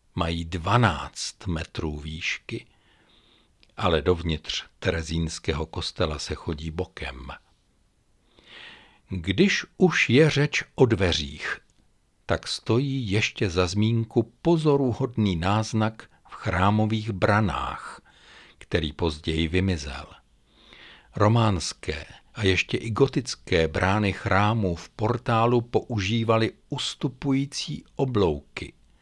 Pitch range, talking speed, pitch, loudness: 85-115 Hz, 85 wpm, 100 Hz, -25 LUFS